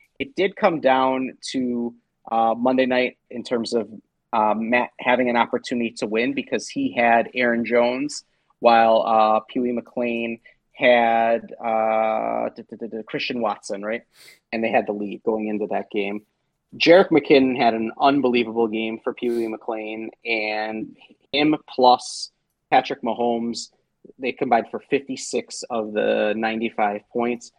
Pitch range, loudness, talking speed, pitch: 110-125 Hz, -21 LUFS, 140 wpm, 115 Hz